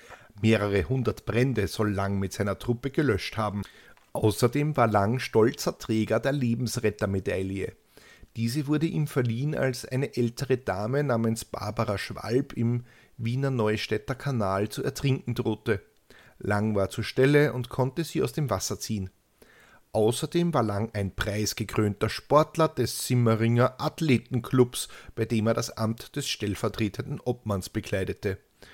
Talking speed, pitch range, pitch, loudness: 135 wpm, 105-130 Hz, 115 Hz, -27 LUFS